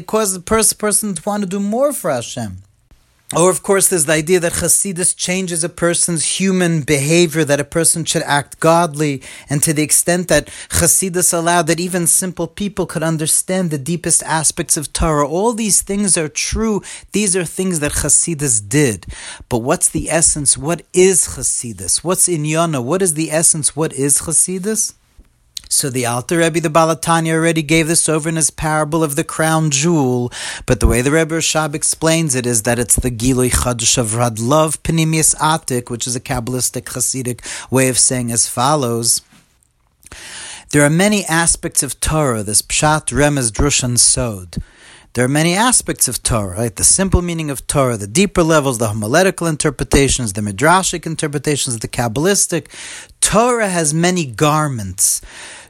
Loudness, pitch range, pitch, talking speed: -15 LUFS, 125-175 Hz, 155 Hz, 170 wpm